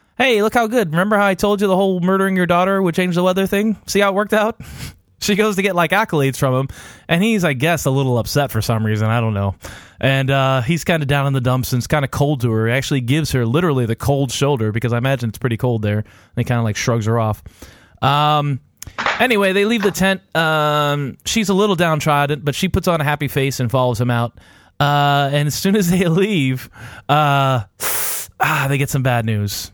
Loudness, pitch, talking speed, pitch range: -17 LUFS, 145 Hz, 240 wpm, 120-180 Hz